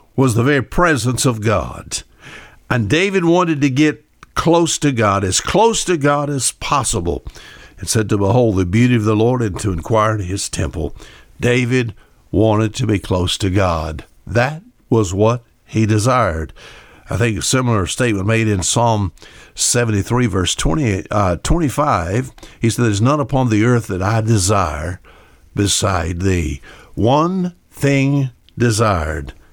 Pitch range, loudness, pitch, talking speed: 95-130 Hz, -16 LUFS, 115 Hz, 155 wpm